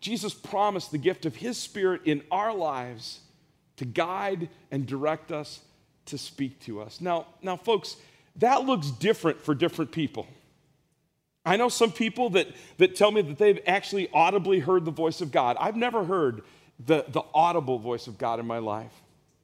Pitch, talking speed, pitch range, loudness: 165 Hz, 175 wpm, 145-195 Hz, -27 LUFS